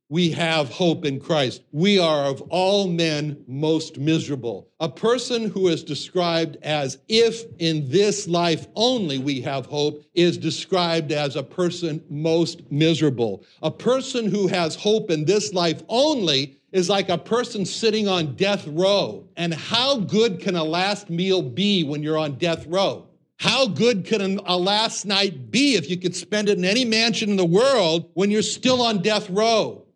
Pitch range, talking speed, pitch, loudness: 155-200 Hz, 175 wpm, 175 Hz, -21 LUFS